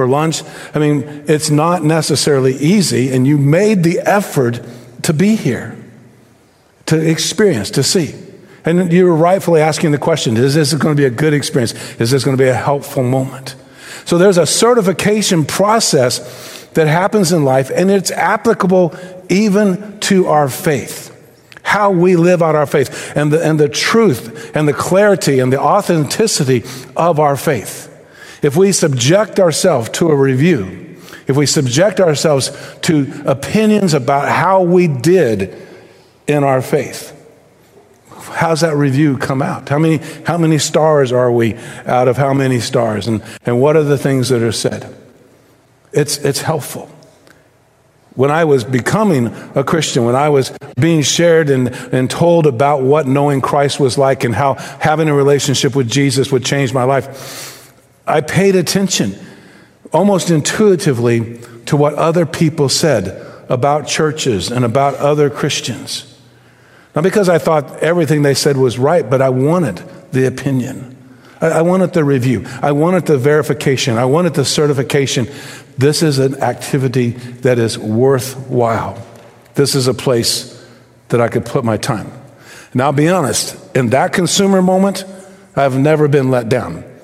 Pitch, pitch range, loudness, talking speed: 145 Hz, 130-165 Hz, -13 LUFS, 160 wpm